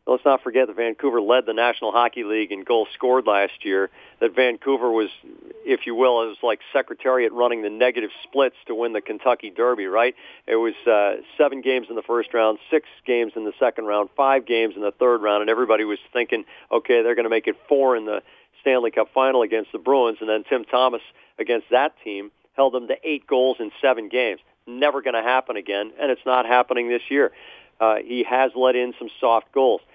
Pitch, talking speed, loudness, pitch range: 120 Hz, 215 wpm, -21 LUFS, 110-130 Hz